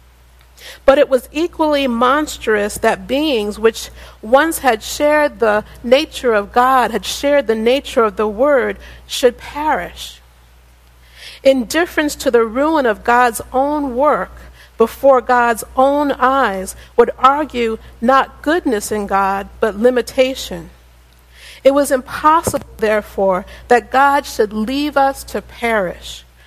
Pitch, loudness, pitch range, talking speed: 245 Hz, -15 LUFS, 210-275 Hz, 125 wpm